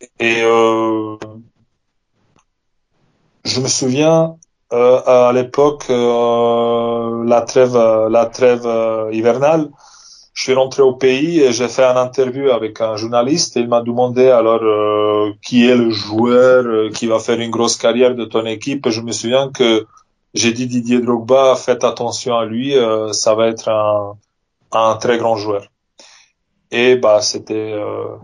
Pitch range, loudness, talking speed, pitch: 110-125 Hz, -14 LUFS, 155 wpm, 115 Hz